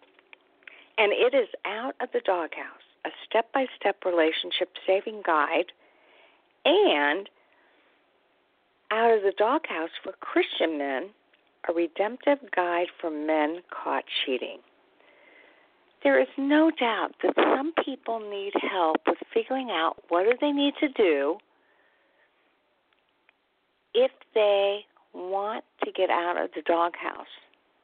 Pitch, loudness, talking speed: 220 Hz, -26 LUFS, 120 wpm